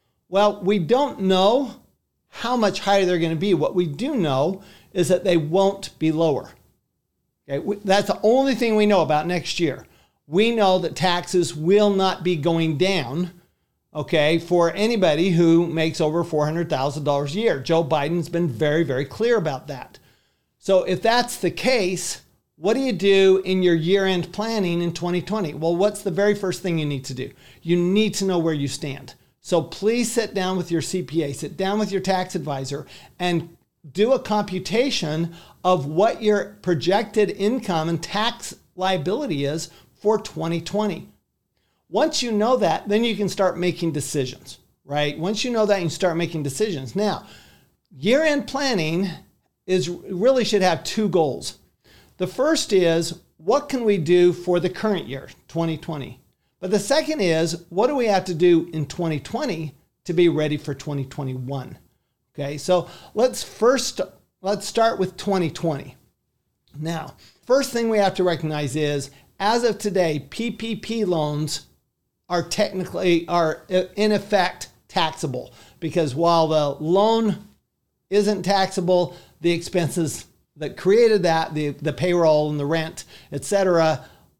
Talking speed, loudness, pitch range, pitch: 155 wpm, -22 LUFS, 160-205 Hz, 180 Hz